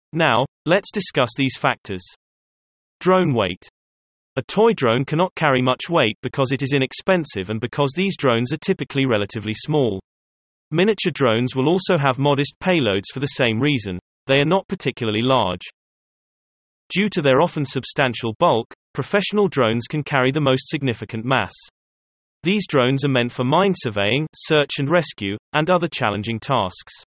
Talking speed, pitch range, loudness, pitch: 155 wpm, 115-160 Hz, -20 LUFS, 135 Hz